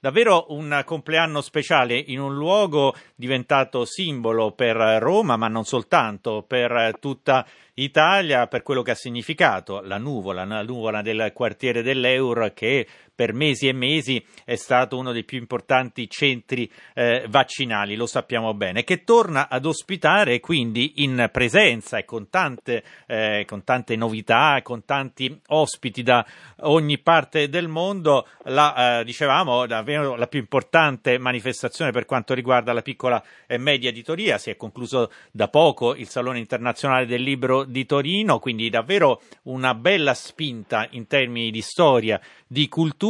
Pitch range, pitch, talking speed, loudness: 120-145 Hz, 130 Hz, 150 wpm, -21 LUFS